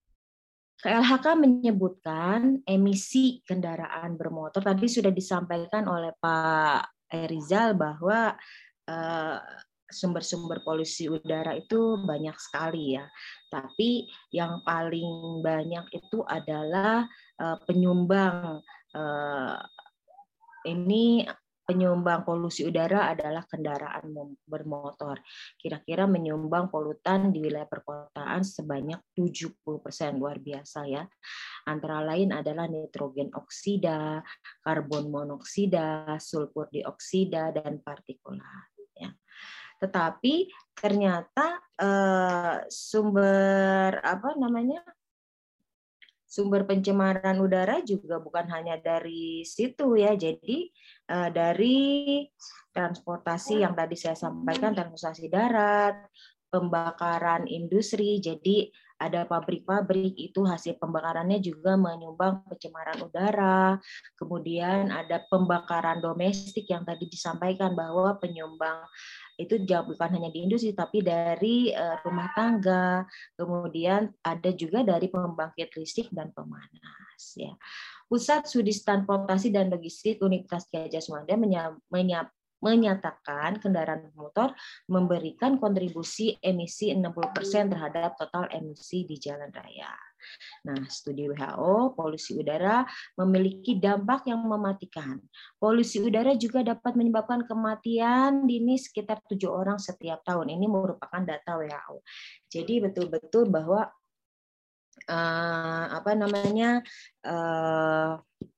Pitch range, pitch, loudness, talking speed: 160-205 Hz, 180 Hz, -28 LUFS, 95 wpm